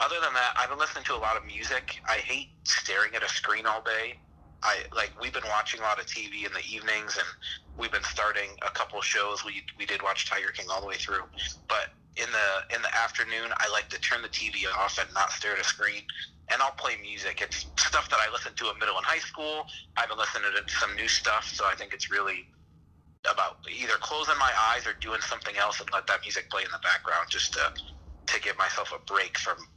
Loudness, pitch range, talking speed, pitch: -28 LUFS, 80-110 Hz, 240 wpm, 80 Hz